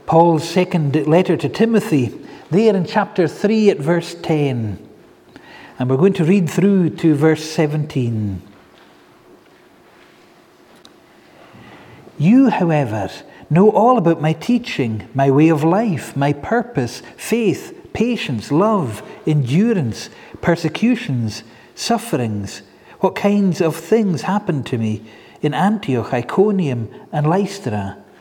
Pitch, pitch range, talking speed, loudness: 160 Hz, 130-195 Hz, 110 wpm, -17 LUFS